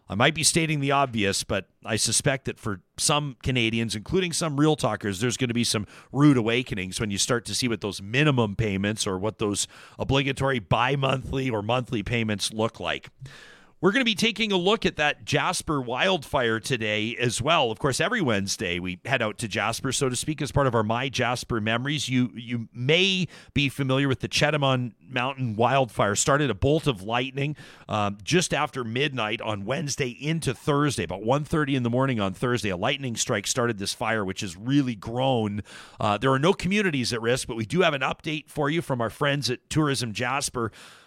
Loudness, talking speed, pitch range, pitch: -25 LUFS, 200 wpm, 110-145 Hz, 125 Hz